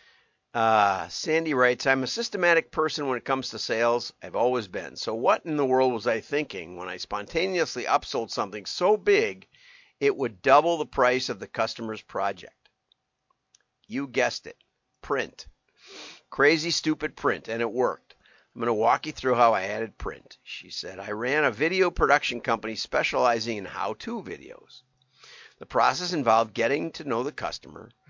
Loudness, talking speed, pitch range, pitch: -26 LUFS, 170 wpm, 120-170 Hz, 135 Hz